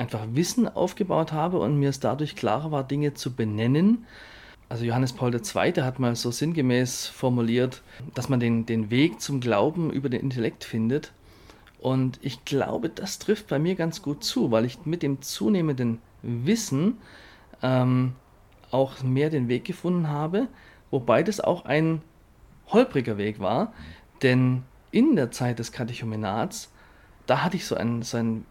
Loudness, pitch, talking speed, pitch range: -26 LUFS, 130 Hz, 160 wpm, 115-150 Hz